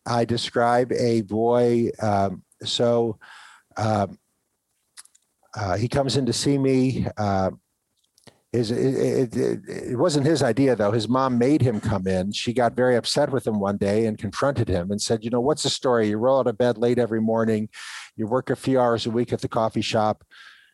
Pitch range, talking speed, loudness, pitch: 110-125 Hz, 195 wpm, -23 LUFS, 120 Hz